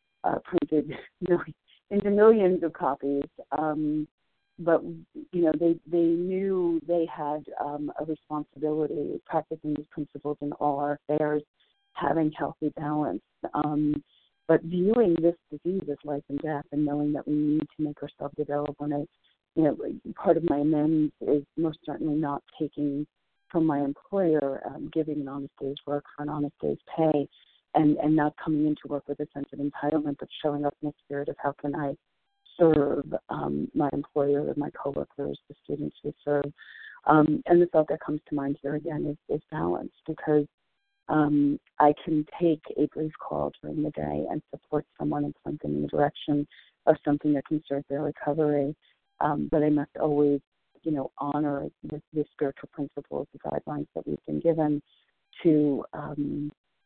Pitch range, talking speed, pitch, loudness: 145-155 Hz, 170 wpm, 150 Hz, -28 LUFS